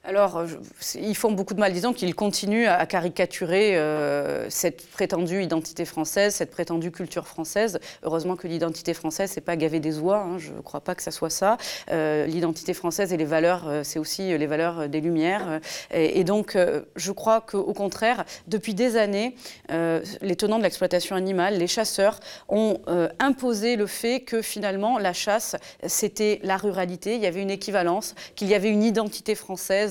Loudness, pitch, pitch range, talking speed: -25 LUFS, 190 Hz, 170-210 Hz, 185 wpm